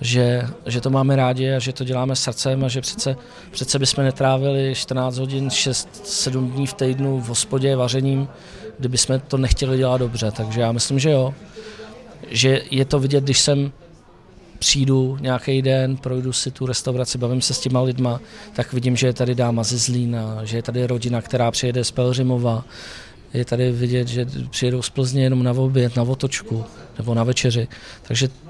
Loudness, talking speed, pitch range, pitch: -20 LUFS, 180 wpm, 125-135 Hz, 130 Hz